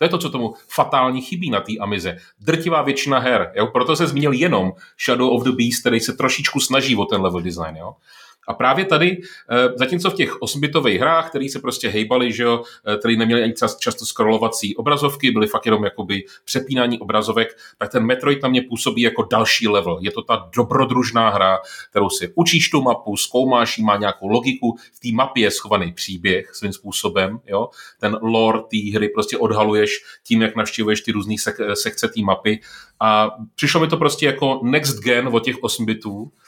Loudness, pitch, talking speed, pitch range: -18 LUFS, 120 Hz, 190 wpm, 105-135 Hz